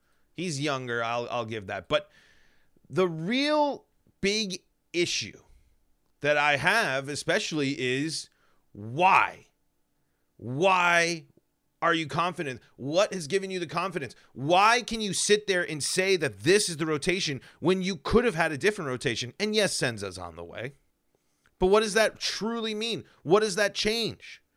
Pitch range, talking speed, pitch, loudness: 135-195 Hz, 155 wpm, 170 Hz, -26 LUFS